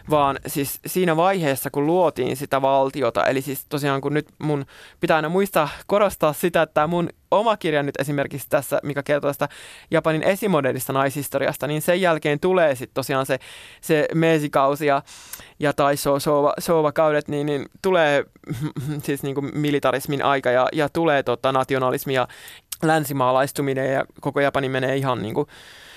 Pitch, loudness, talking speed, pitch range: 145 Hz, -21 LUFS, 150 wpm, 135-155 Hz